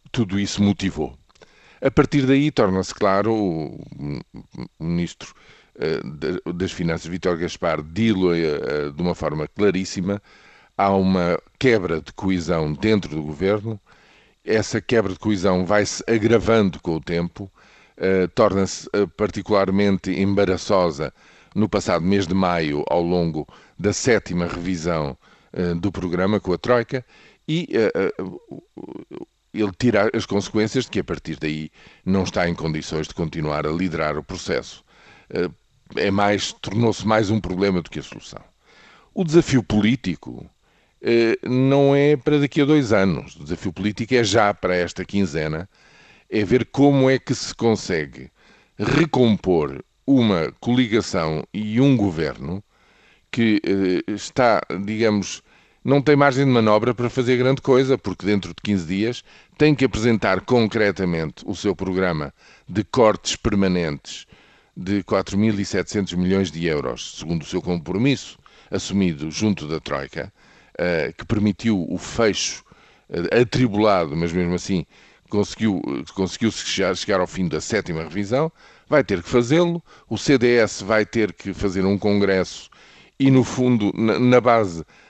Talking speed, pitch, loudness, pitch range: 135 wpm, 100 Hz, -21 LUFS, 90-115 Hz